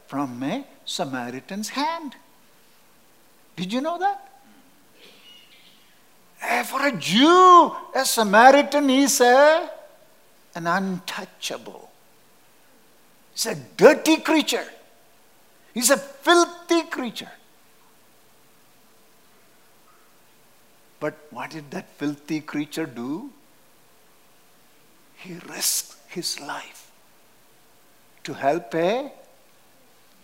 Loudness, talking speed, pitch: -21 LUFS, 75 wpm, 265 Hz